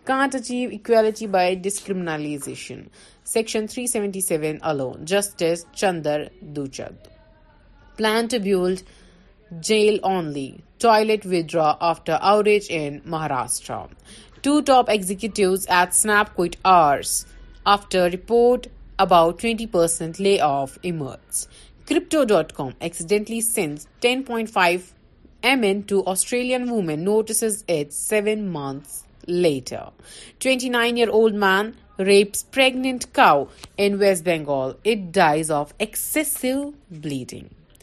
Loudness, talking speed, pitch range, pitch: -21 LUFS, 115 wpm, 165-225 Hz, 195 Hz